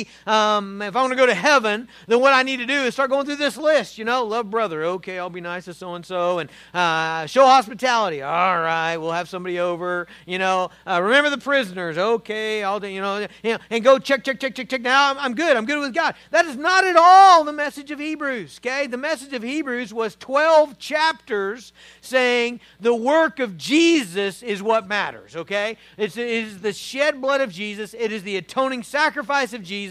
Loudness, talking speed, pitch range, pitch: -20 LUFS, 215 wpm, 195-275 Hz, 235 Hz